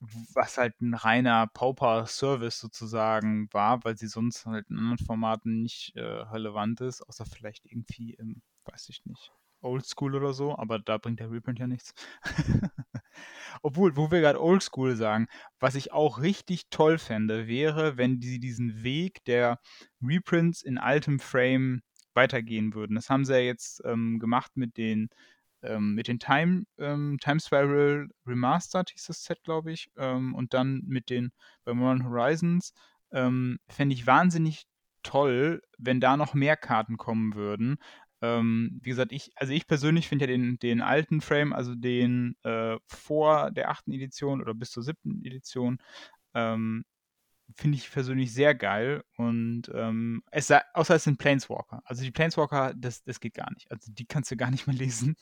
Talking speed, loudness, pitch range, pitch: 170 wpm, -28 LUFS, 115-145 Hz, 125 Hz